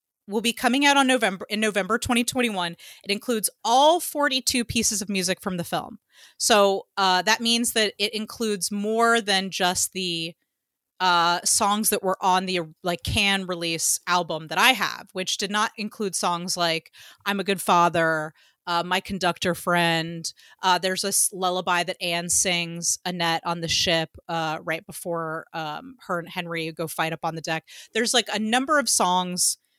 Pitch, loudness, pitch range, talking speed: 185 Hz, -23 LUFS, 170-215 Hz, 175 wpm